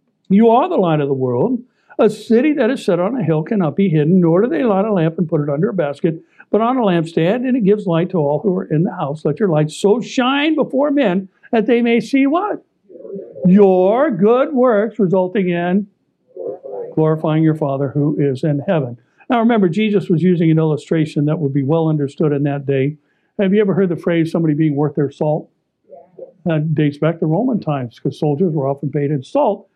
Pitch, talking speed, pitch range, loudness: 180 Hz, 220 wpm, 155-215 Hz, -16 LUFS